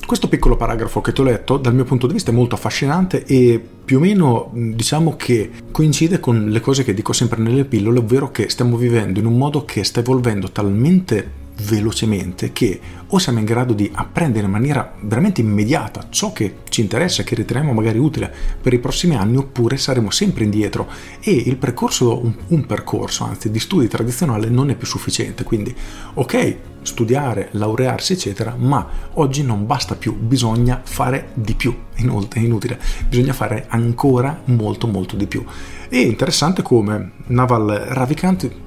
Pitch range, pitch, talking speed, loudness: 110-135 Hz, 120 Hz, 175 wpm, -17 LUFS